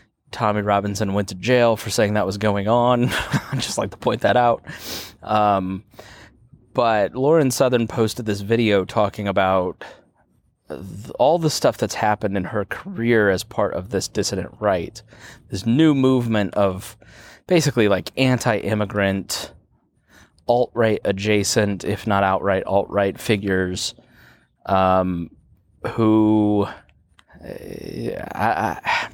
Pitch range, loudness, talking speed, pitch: 100-115 Hz, -20 LUFS, 125 wpm, 105 Hz